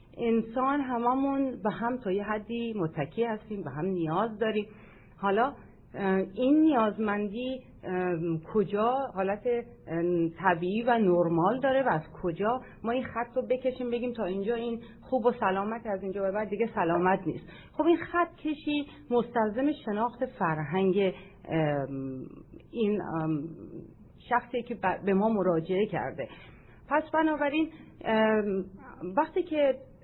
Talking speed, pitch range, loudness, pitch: 130 wpm, 185-245 Hz, -29 LUFS, 215 Hz